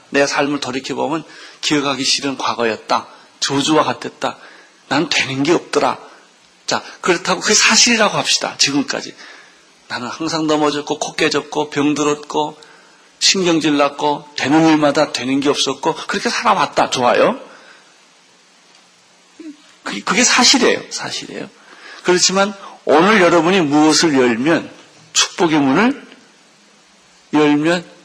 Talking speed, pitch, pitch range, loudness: 270 characters per minute, 150 Hz, 145-175 Hz, -15 LUFS